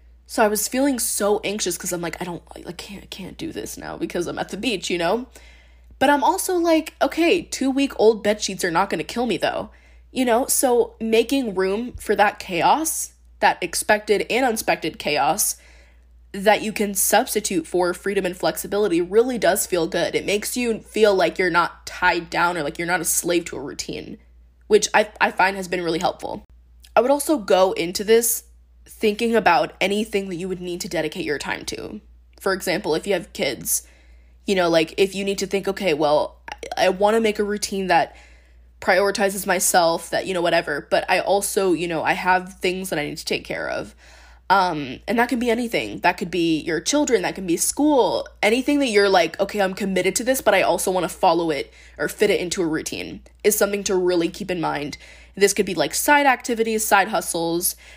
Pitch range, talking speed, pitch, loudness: 170-220 Hz, 215 wpm, 195 Hz, -21 LUFS